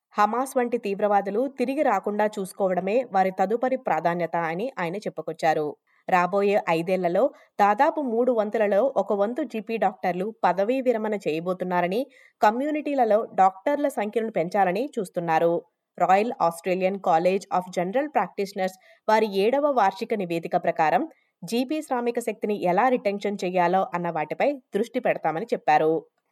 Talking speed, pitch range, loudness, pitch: 115 wpm, 180-245 Hz, -24 LUFS, 205 Hz